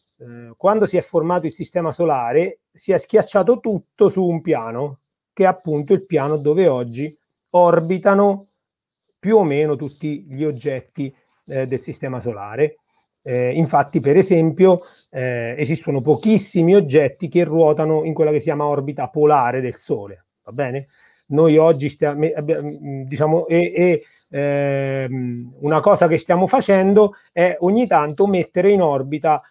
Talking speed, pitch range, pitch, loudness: 145 wpm, 145-180 Hz, 155 Hz, -18 LUFS